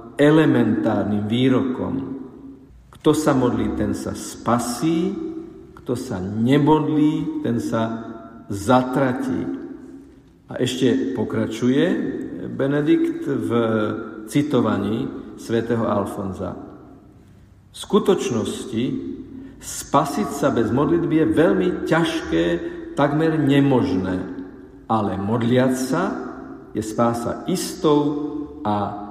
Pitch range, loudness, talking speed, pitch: 110-160 Hz, -21 LUFS, 80 wpm, 130 Hz